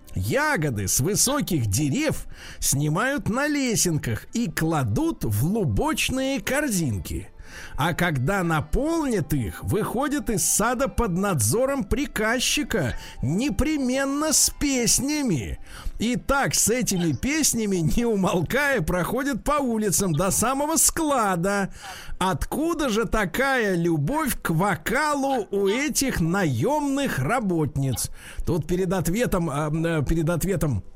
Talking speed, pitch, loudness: 105 wpm, 195 Hz, -23 LUFS